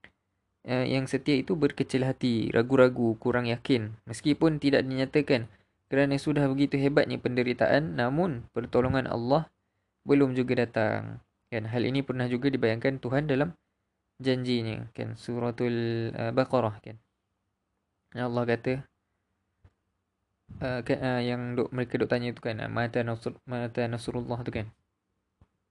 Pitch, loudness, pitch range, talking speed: 120 Hz, -28 LUFS, 110-130 Hz, 130 wpm